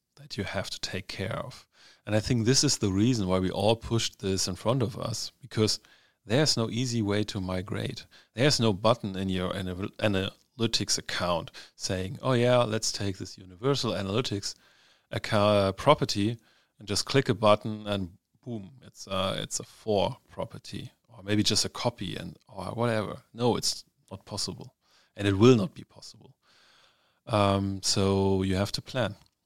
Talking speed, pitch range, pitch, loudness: 170 wpm, 100-120 Hz, 105 Hz, -28 LUFS